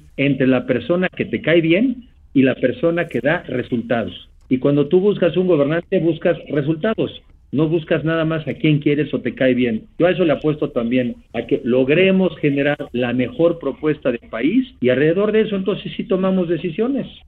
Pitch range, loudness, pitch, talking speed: 130-180 Hz, -18 LUFS, 155 Hz, 190 wpm